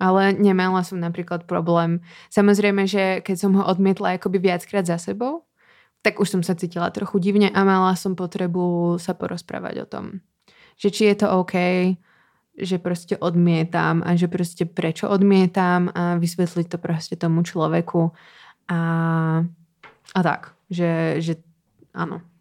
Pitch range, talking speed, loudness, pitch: 170-195 Hz, 145 wpm, -21 LUFS, 180 Hz